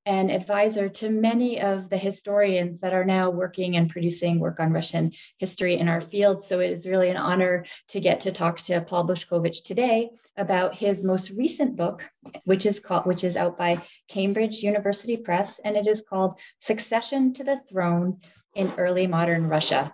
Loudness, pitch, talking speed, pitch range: -25 LUFS, 190 Hz, 185 wpm, 175-205 Hz